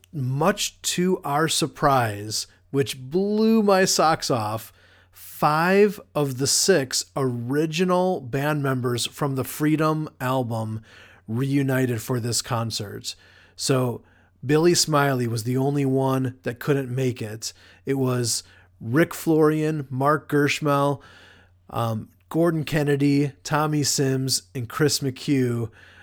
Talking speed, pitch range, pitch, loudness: 115 wpm, 115-150 Hz, 135 Hz, -23 LUFS